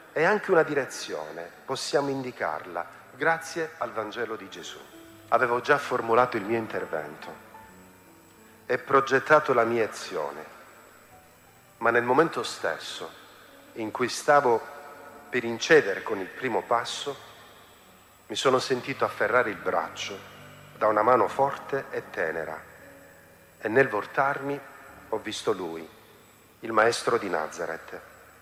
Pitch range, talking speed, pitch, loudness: 105-140 Hz, 120 wpm, 120 Hz, -26 LUFS